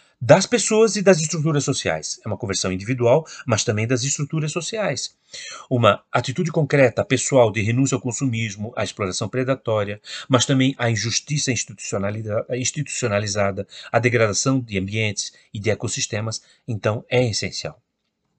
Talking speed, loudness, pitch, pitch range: 135 wpm, -21 LUFS, 120 Hz, 110-140 Hz